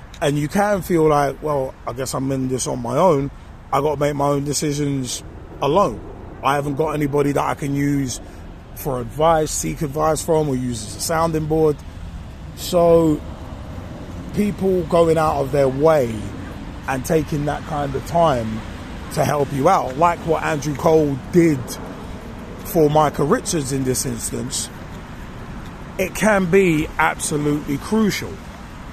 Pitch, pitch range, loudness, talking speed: 145 Hz, 130-160 Hz, -19 LUFS, 155 wpm